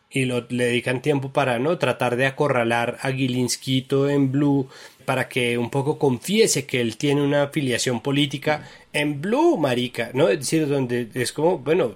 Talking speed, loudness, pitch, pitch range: 175 wpm, -22 LUFS, 135 Hz, 125-145 Hz